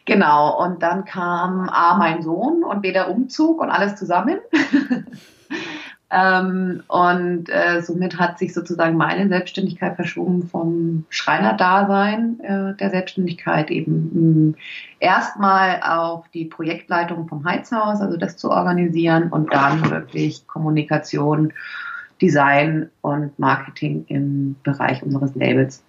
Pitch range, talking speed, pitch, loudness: 155-190 Hz, 115 wpm, 175 Hz, -19 LUFS